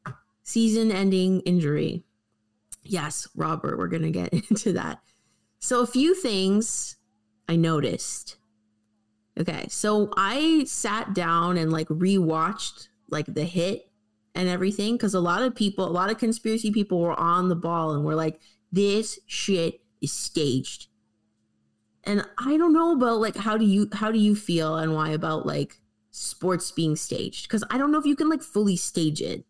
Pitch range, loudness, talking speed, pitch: 140-210 Hz, -25 LUFS, 165 wpm, 175 Hz